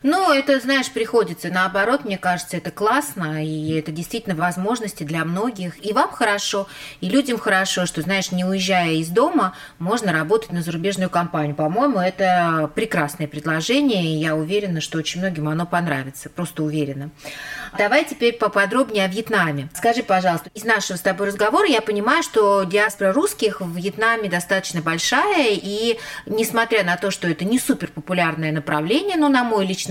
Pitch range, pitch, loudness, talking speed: 160-215 Hz, 185 Hz, -20 LUFS, 165 wpm